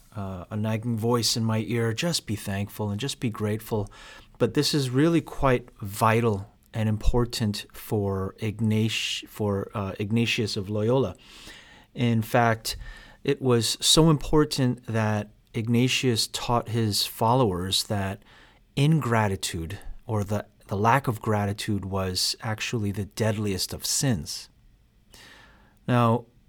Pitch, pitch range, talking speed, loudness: 110 Hz, 105-120 Hz, 125 wpm, -25 LUFS